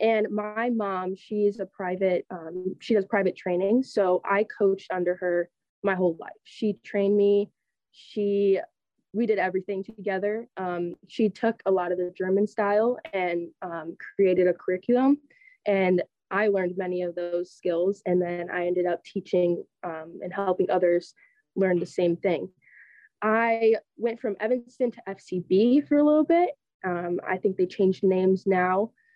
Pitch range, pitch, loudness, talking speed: 180-215 Hz, 195 Hz, -26 LUFS, 165 wpm